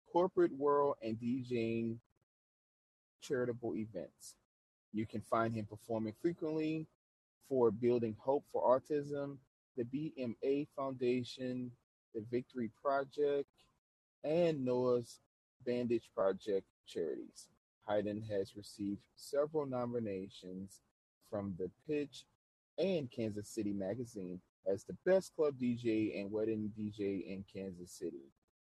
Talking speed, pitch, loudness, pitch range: 105 wpm, 120 Hz, -39 LUFS, 105-140 Hz